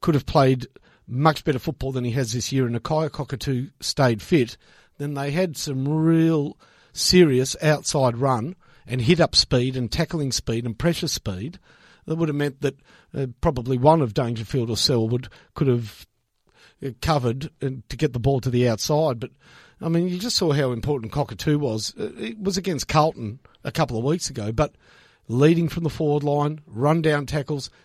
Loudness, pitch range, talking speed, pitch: -23 LUFS, 125-155 Hz, 185 wpm, 140 Hz